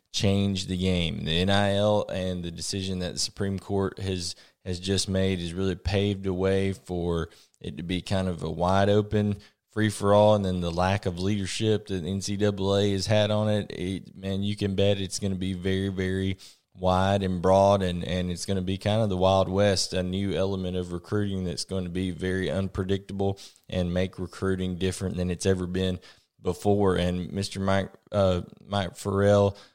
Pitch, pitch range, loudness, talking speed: 95 Hz, 90-100 Hz, -27 LUFS, 195 wpm